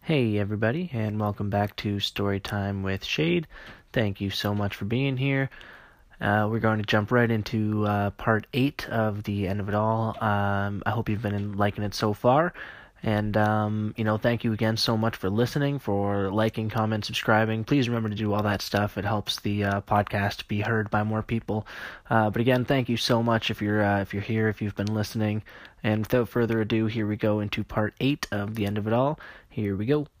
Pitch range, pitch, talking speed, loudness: 105-115 Hz, 110 Hz, 215 wpm, -26 LUFS